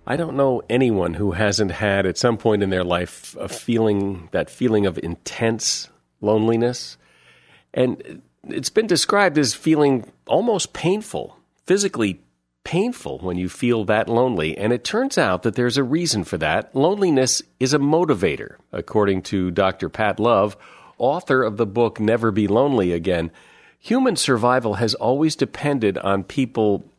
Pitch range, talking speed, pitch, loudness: 100-135 Hz, 155 wpm, 115 Hz, -20 LUFS